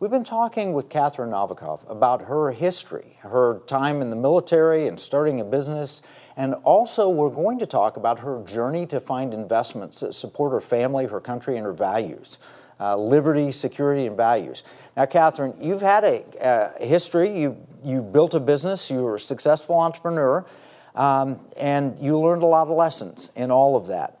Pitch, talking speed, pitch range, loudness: 145 Hz, 180 wpm, 130-165 Hz, -22 LUFS